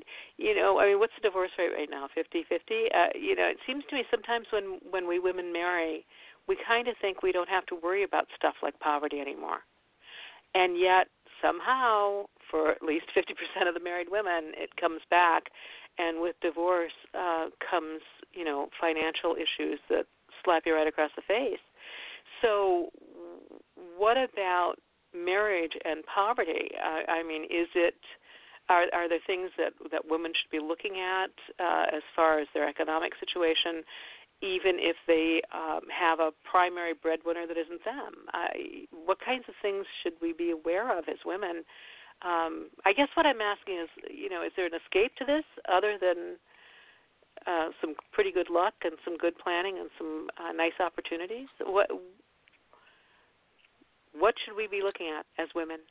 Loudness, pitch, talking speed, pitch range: -30 LUFS, 175 Hz, 175 wpm, 165-210 Hz